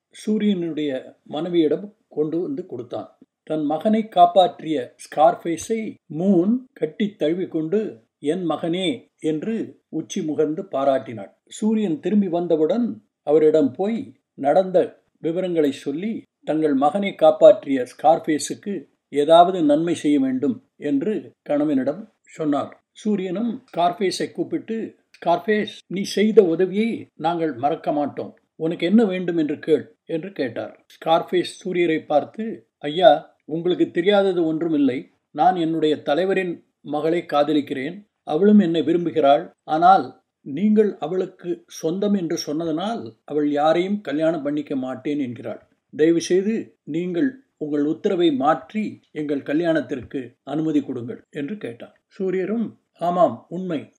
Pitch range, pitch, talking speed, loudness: 155-215 Hz, 175 Hz, 105 wpm, -21 LUFS